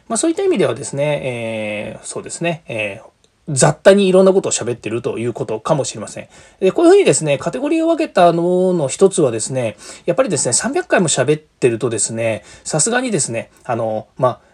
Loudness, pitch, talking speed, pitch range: -16 LUFS, 150 Hz, 435 characters per minute, 115-190 Hz